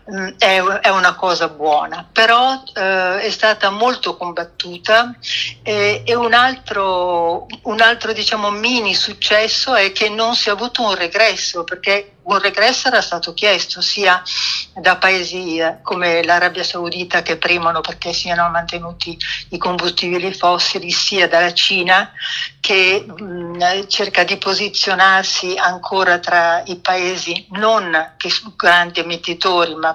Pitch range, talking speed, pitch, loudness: 175-210 Hz, 130 wpm, 185 Hz, -15 LUFS